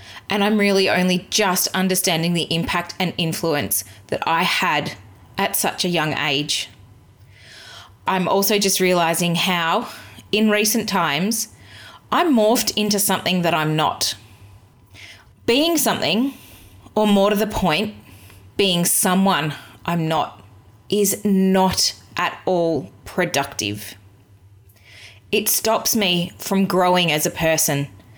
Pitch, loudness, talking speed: 170 Hz, -19 LUFS, 120 wpm